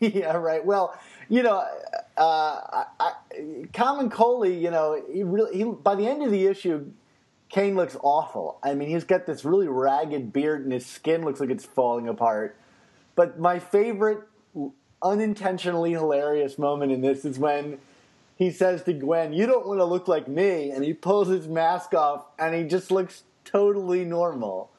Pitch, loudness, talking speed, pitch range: 175 Hz, -25 LUFS, 175 wpm, 145-205 Hz